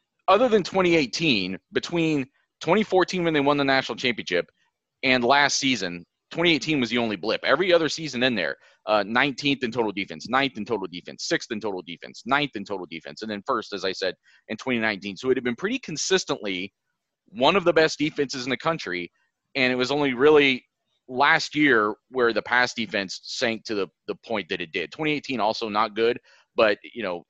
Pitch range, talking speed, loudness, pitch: 110-150 Hz, 195 wpm, -24 LUFS, 130 Hz